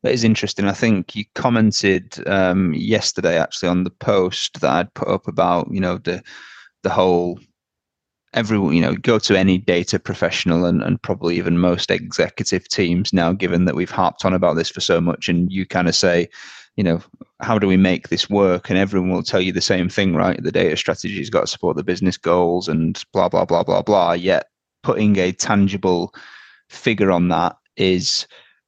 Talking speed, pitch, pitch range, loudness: 200 wpm, 95 Hz, 90-100 Hz, -18 LUFS